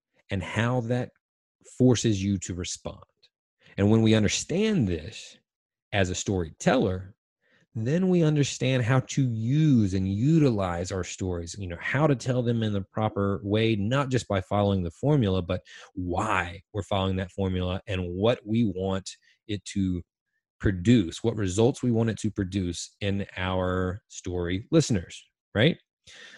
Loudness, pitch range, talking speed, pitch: -26 LUFS, 95-120 Hz, 150 wpm, 100 Hz